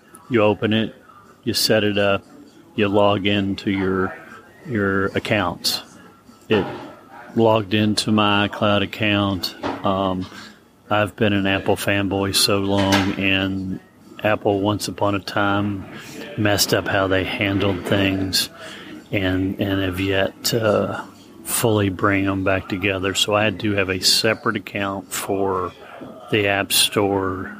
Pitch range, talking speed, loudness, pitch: 95-105 Hz, 130 wpm, -20 LUFS, 100 Hz